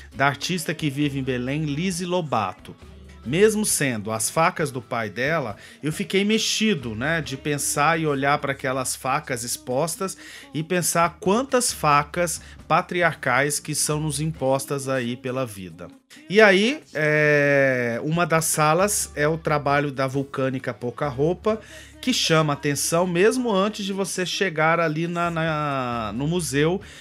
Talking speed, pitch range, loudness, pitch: 145 wpm, 135-175 Hz, -22 LUFS, 150 Hz